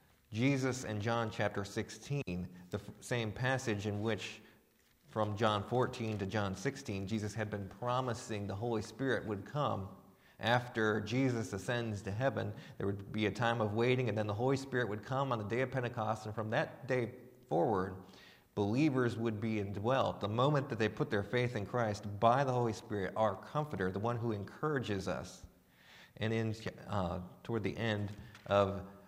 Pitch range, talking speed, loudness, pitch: 100-125 Hz, 175 wpm, -36 LUFS, 110 Hz